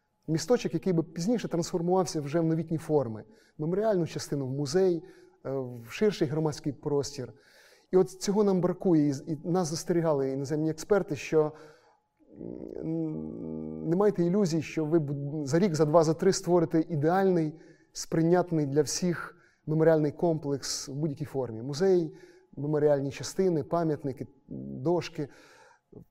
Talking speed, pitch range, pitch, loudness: 125 wpm, 145-180 Hz, 160 Hz, -28 LUFS